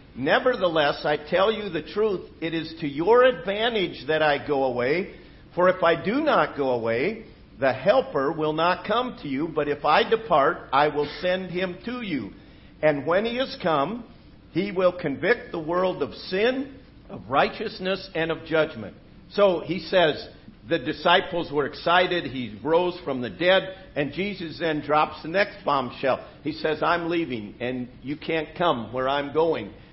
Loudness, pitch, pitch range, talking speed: -24 LUFS, 165 Hz, 150-190 Hz, 170 wpm